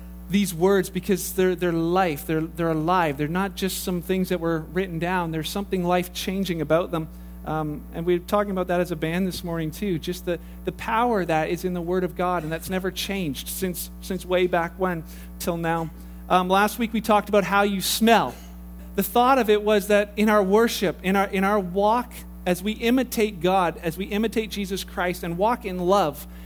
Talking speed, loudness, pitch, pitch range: 215 wpm, -24 LUFS, 185 Hz, 165-200 Hz